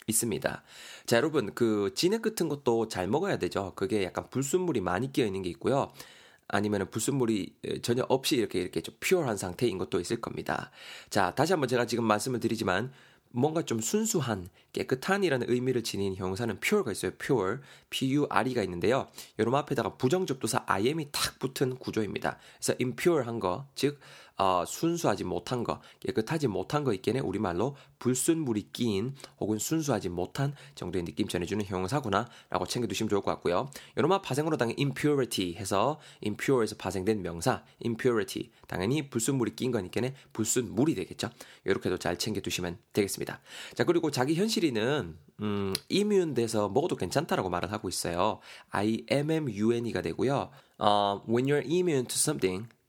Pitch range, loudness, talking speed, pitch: 105-140 Hz, -30 LUFS, 420 characters per minute, 120 Hz